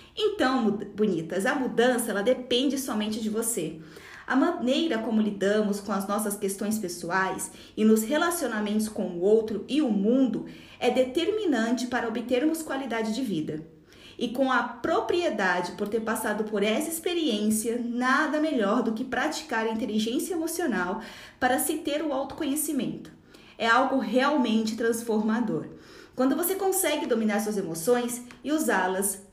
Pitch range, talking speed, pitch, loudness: 215-270 Hz, 140 wpm, 235 Hz, -27 LUFS